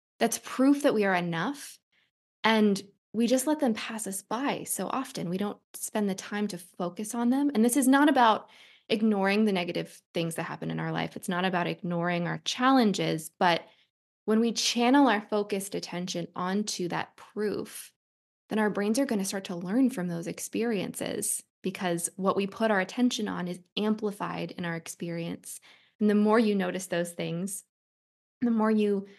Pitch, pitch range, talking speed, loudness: 200 Hz, 175-225 Hz, 185 wpm, -28 LUFS